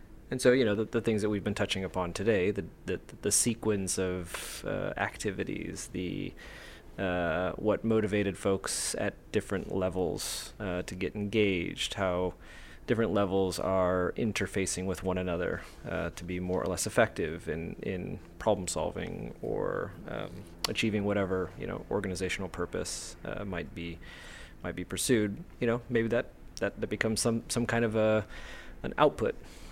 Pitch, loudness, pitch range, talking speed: 95 Hz, -32 LUFS, 90-110 Hz, 160 wpm